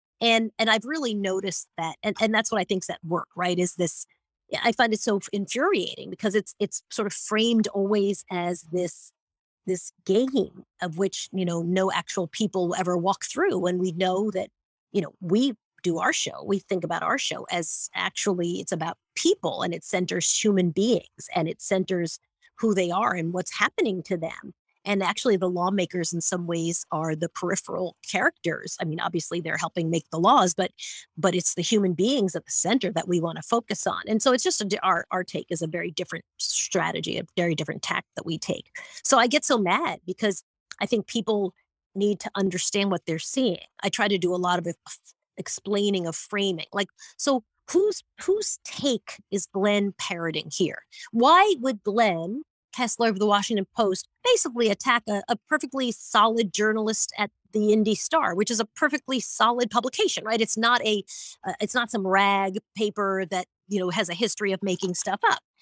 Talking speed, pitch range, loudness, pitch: 195 wpm, 180-225 Hz, -25 LUFS, 200 Hz